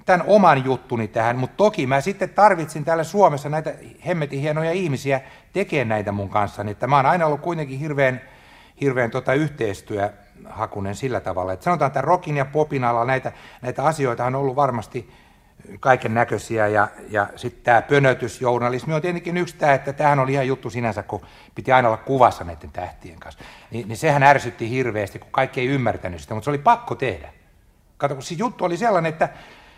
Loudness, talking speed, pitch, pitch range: -21 LUFS, 185 wpm, 130 Hz, 115-155 Hz